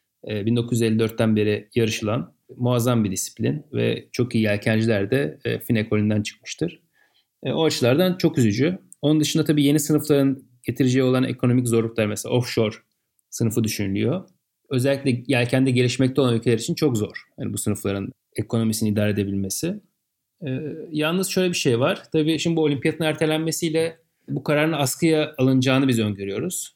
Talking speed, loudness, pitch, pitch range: 135 wpm, -22 LUFS, 130 Hz, 110-155 Hz